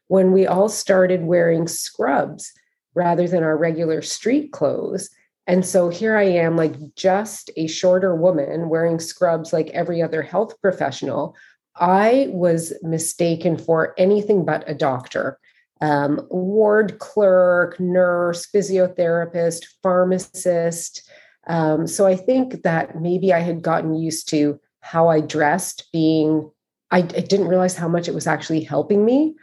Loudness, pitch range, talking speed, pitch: -19 LUFS, 165-190 Hz, 140 wpm, 175 Hz